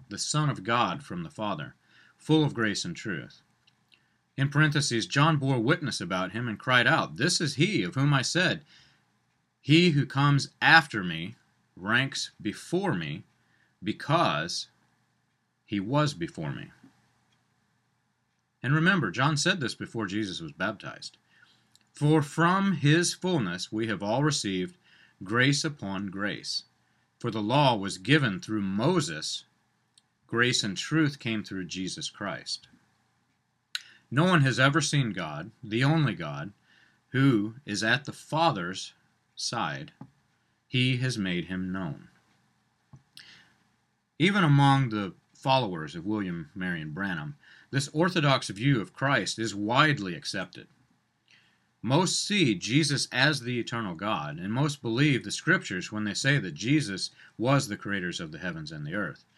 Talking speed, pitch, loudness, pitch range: 140 wpm, 135 Hz, -27 LUFS, 110-155 Hz